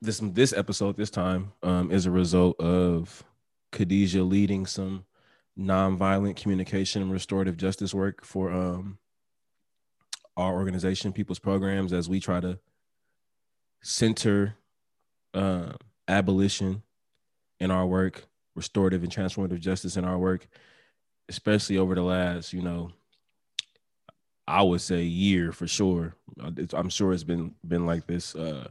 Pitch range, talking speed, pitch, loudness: 90-100 Hz, 130 wpm, 95 Hz, -27 LUFS